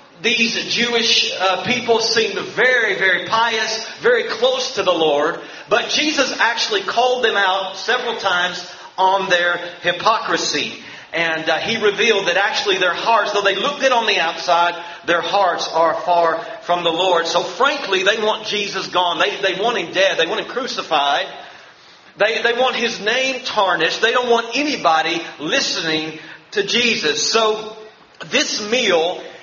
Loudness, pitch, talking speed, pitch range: -17 LUFS, 205 Hz, 155 wpm, 175-235 Hz